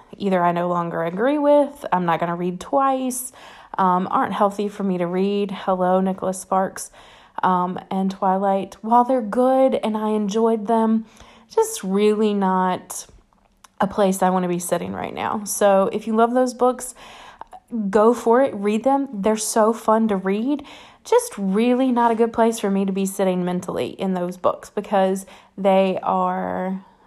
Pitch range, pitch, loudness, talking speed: 190-235 Hz, 205 Hz, -20 LUFS, 175 wpm